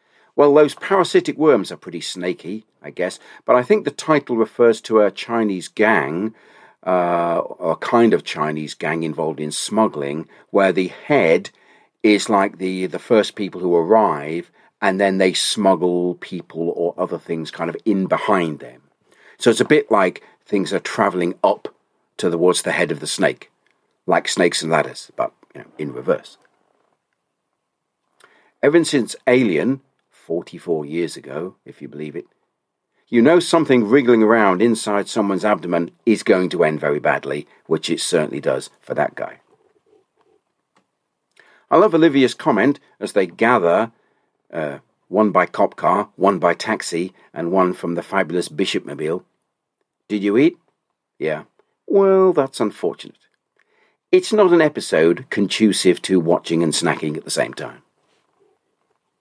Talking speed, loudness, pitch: 150 wpm, -18 LUFS, 105 Hz